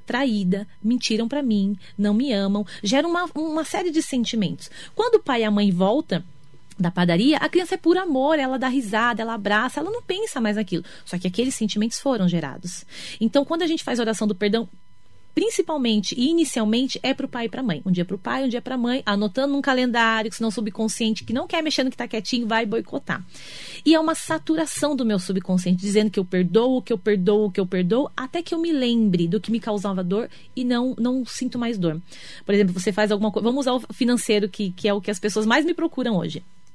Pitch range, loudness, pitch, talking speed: 205-270 Hz, -22 LUFS, 230 Hz, 230 wpm